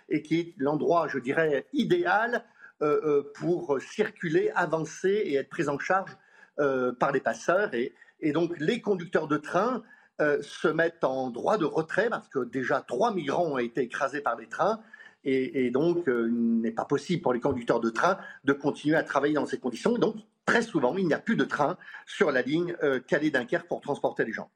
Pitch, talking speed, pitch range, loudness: 155 Hz, 205 wpm, 140-185 Hz, -28 LUFS